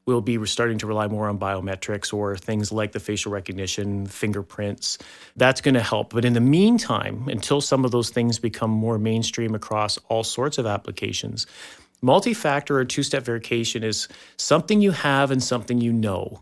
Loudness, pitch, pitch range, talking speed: -23 LUFS, 115 Hz, 105-130 Hz, 185 wpm